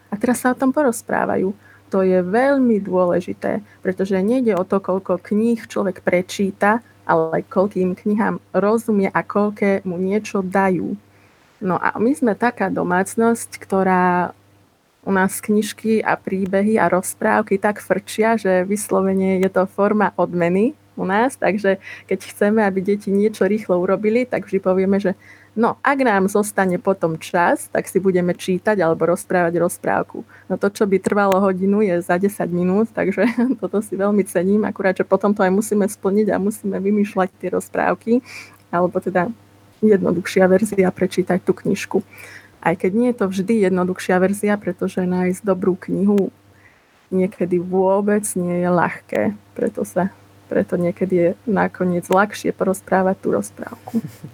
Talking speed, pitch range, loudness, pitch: 150 wpm, 180-210 Hz, -19 LUFS, 190 Hz